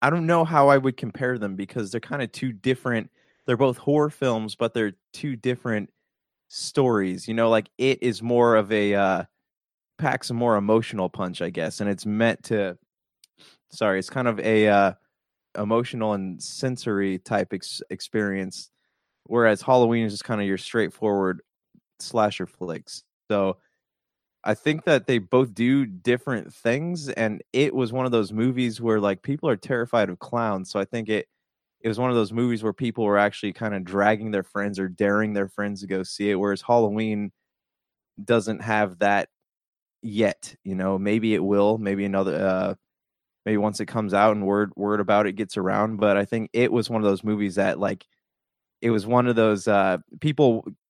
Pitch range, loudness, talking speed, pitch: 100-120 Hz, -24 LUFS, 185 wpm, 110 Hz